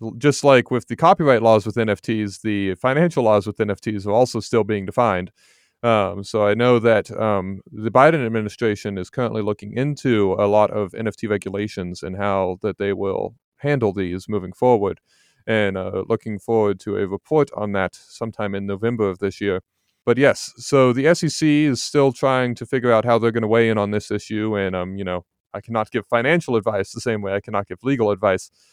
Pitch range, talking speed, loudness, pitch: 100-120 Hz, 205 wpm, -20 LUFS, 110 Hz